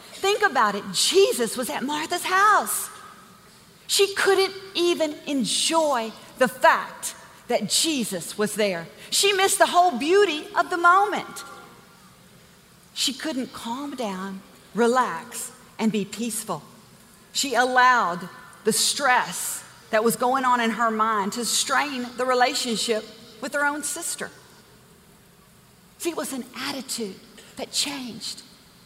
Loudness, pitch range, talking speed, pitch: -23 LUFS, 220-315 Hz, 125 wpm, 250 Hz